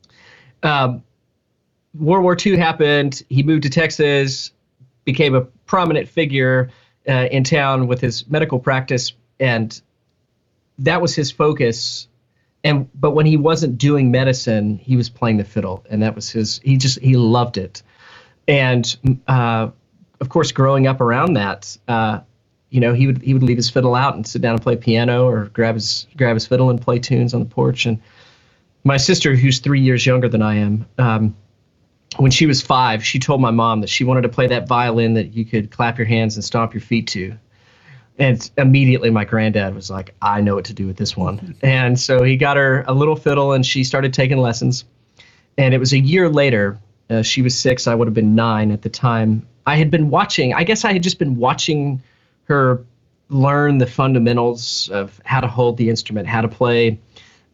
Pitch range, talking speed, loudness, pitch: 115-135 Hz, 195 wpm, -16 LUFS, 125 Hz